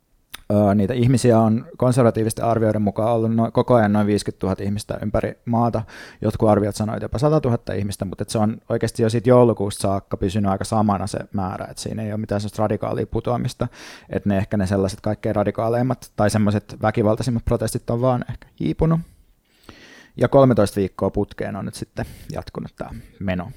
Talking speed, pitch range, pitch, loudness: 180 wpm, 105-120 Hz, 110 Hz, -21 LUFS